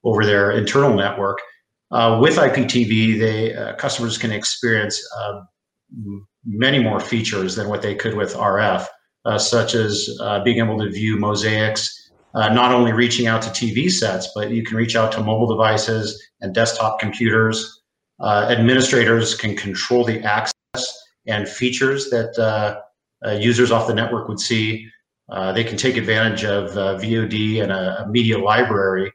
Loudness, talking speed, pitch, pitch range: -18 LUFS, 165 wpm, 110 Hz, 105-115 Hz